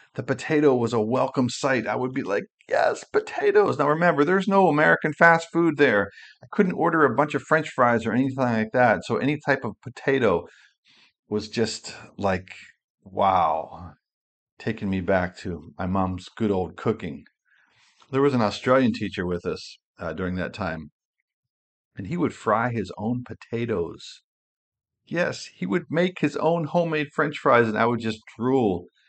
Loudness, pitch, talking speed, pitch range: -23 LUFS, 125 Hz, 170 wpm, 105-150 Hz